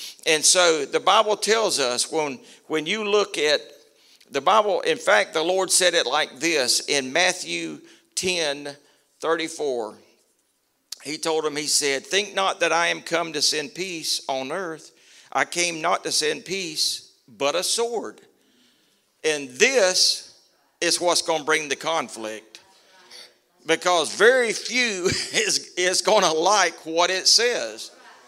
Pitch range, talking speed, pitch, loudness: 155-205 Hz, 150 wpm, 170 Hz, -21 LUFS